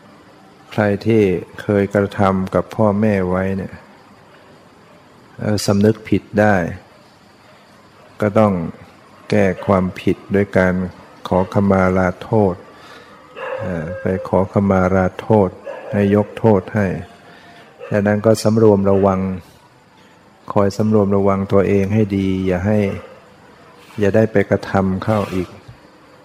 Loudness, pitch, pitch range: -17 LUFS, 100 Hz, 95-105 Hz